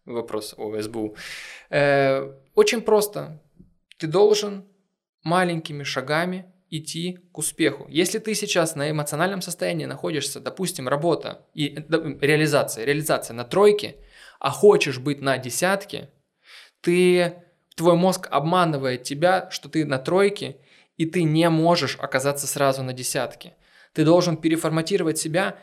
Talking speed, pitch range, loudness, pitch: 120 wpm, 140-180 Hz, -22 LUFS, 160 Hz